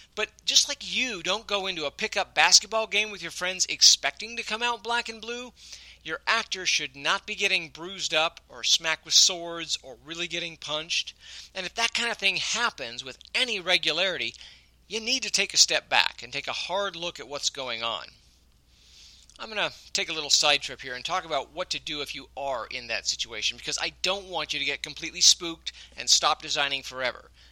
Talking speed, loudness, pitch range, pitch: 210 wpm, -25 LUFS, 145-200 Hz, 170 Hz